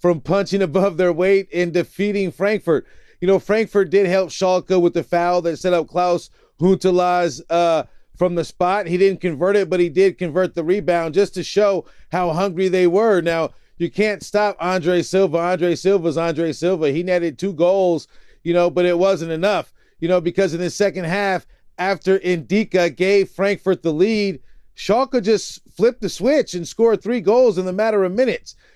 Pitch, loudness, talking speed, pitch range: 185 Hz, -19 LUFS, 190 wpm, 175-195 Hz